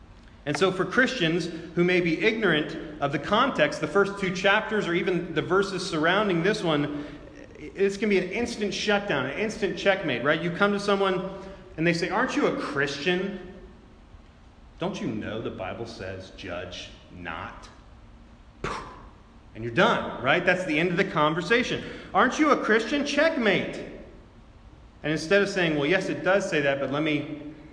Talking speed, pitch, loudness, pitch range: 170 wpm, 175 Hz, -25 LUFS, 145-195 Hz